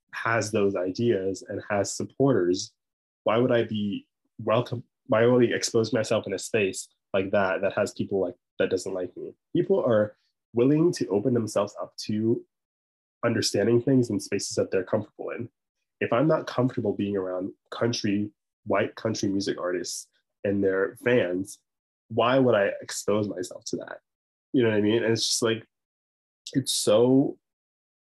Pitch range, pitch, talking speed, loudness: 100-120 Hz, 110 Hz, 165 wpm, -26 LUFS